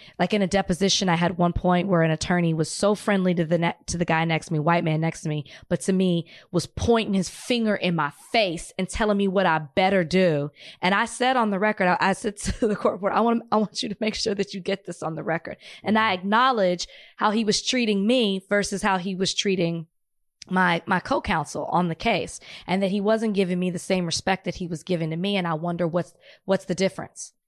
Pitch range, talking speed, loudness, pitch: 170-205 Hz, 250 wpm, -24 LUFS, 185 Hz